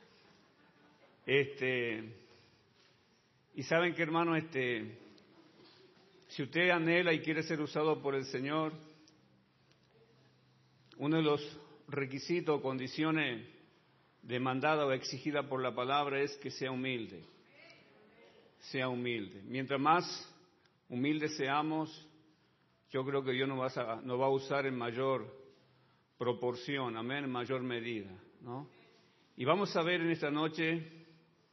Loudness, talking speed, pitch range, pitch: -35 LUFS, 120 wpm, 125-155 Hz, 140 Hz